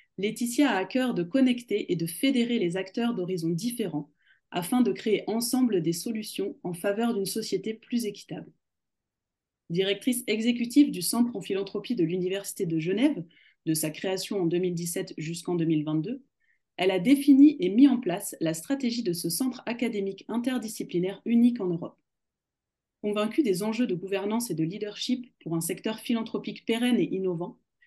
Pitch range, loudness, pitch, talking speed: 180-240 Hz, -27 LUFS, 205 Hz, 160 wpm